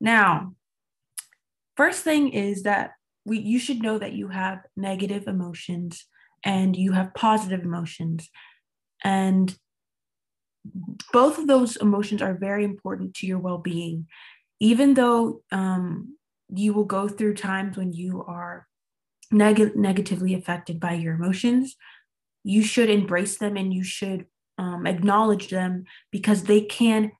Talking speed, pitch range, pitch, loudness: 135 wpm, 180-215 Hz, 195 Hz, -23 LUFS